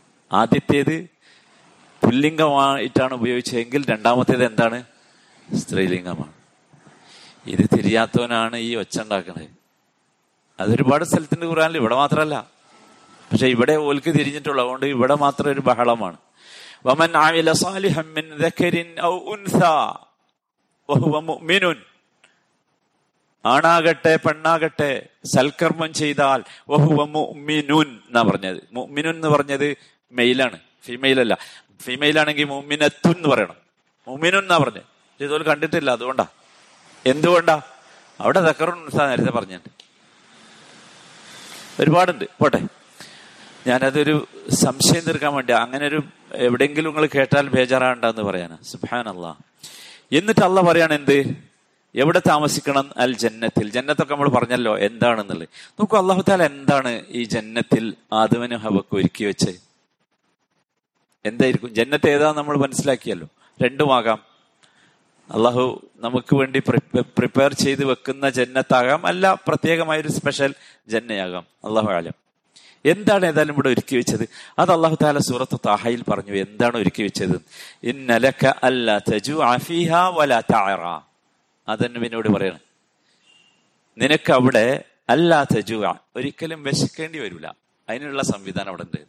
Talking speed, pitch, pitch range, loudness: 90 wpm, 140 Hz, 125-155 Hz, -19 LUFS